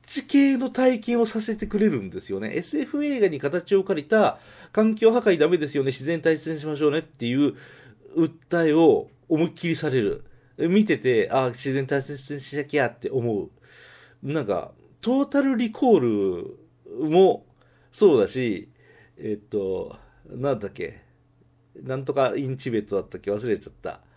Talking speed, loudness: 320 characters per minute, -23 LUFS